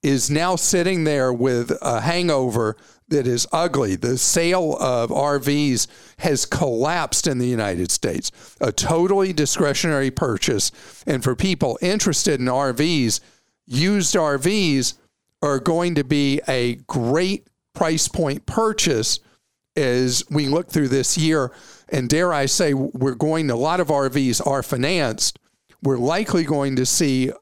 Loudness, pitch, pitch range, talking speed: -20 LUFS, 145 Hz, 130-170 Hz, 140 wpm